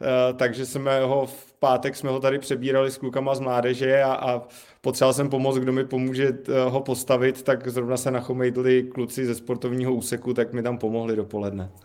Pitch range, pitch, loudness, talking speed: 125-135 Hz, 130 Hz, -24 LUFS, 180 wpm